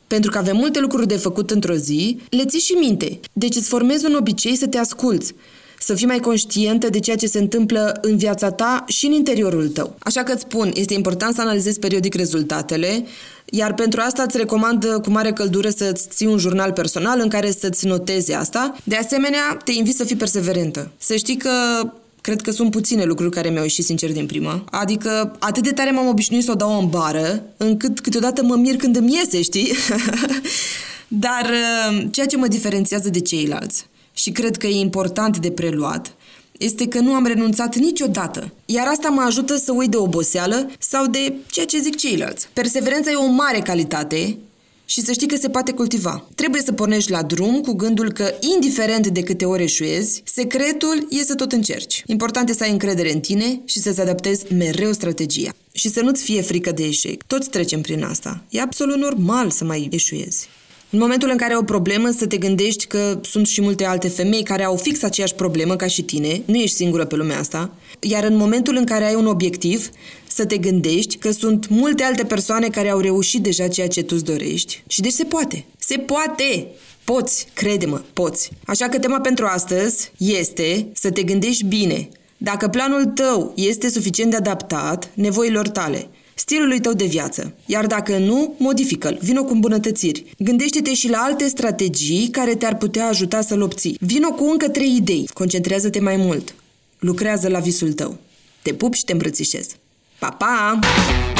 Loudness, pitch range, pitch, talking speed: -18 LUFS, 190-245 Hz, 215 Hz, 190 wpm